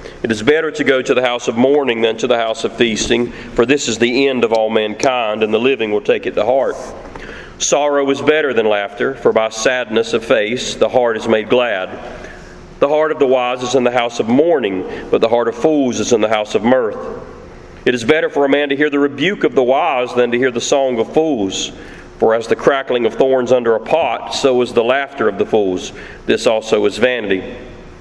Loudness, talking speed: -15 LUFS, 235 wpm